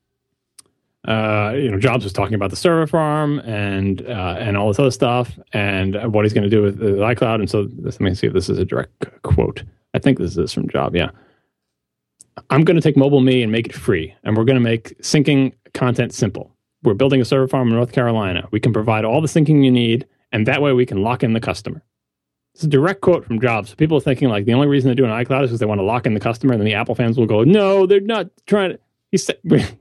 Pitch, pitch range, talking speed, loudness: 125 Hz, 105-135 Hz, 255 wpm, -17 LUFS